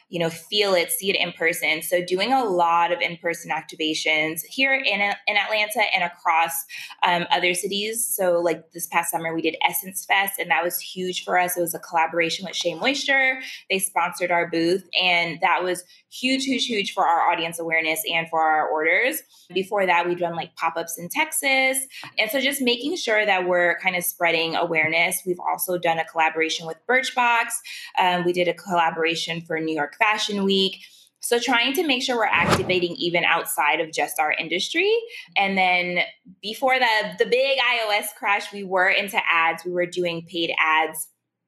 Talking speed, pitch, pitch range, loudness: 190 wpm, 180 Hz, 165-215 Hz, -22 LUFS